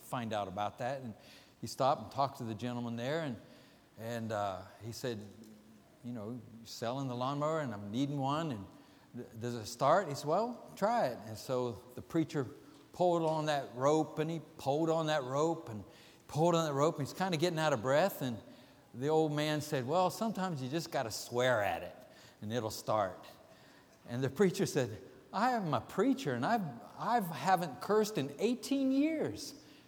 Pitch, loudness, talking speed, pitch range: 140 Hz, -35 LUFS, 200 wpm, 120-165 Hz